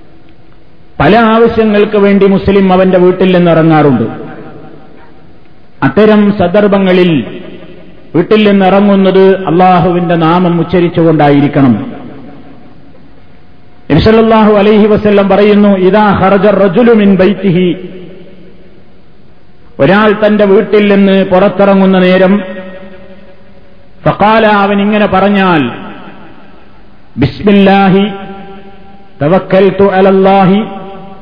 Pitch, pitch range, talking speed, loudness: 195 Hz, 185-205 Hz, 70 wpm, -7 LUFS